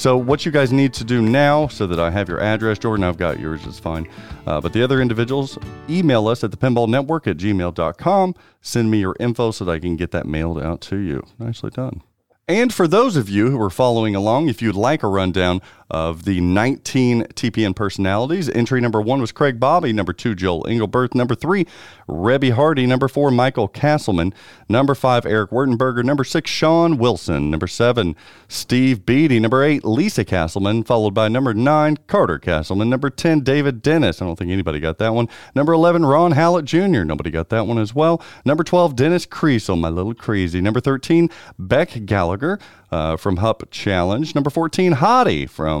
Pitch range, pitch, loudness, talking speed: 95-140 Hz, 115 Hz, -18 LUFS, 195 wpm